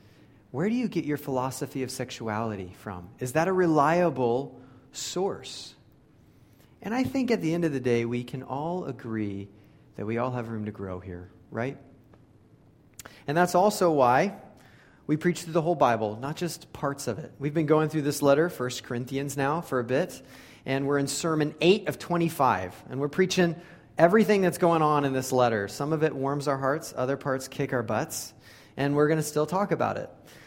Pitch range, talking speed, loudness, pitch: 125-165 Hz, 195 wpm, -27 LUFS, 140 Hz